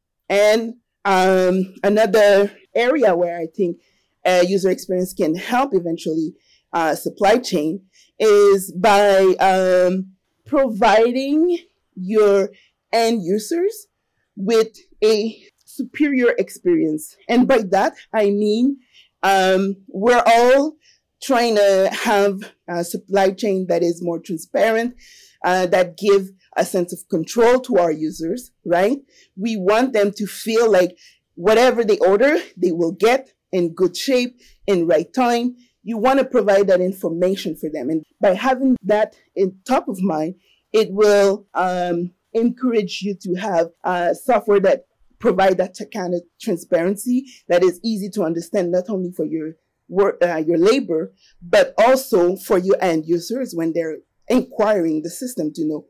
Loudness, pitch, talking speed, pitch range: -18 LUFS, 200 Hz, 140 wpm, 180-235 Hz